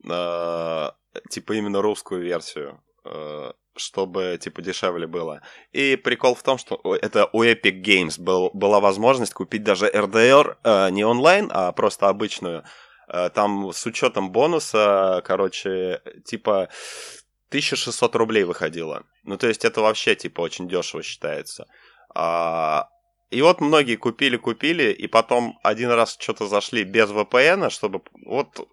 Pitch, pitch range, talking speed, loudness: 110 Hz, 95-125 Hz, 125 wpm, -21 LUFS